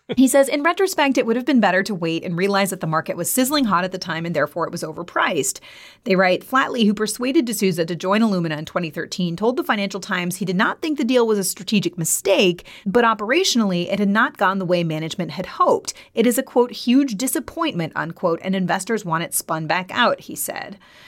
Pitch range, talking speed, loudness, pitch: 175-255 Hz, 225 wpm, -20 LUFS, 200 Hz